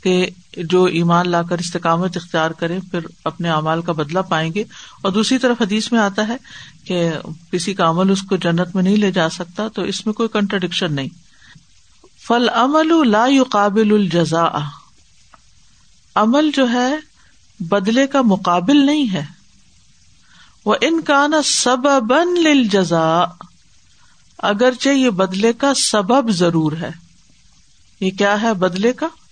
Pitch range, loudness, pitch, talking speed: 175-240 Hz, -16 LUFS, 195 Hz, 140 wpm